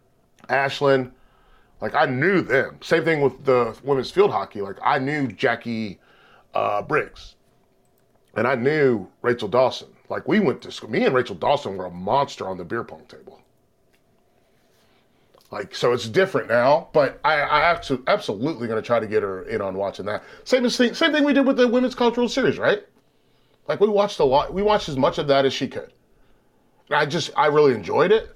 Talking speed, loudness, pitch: 190 wpm, -21 LUFS, 165 Hz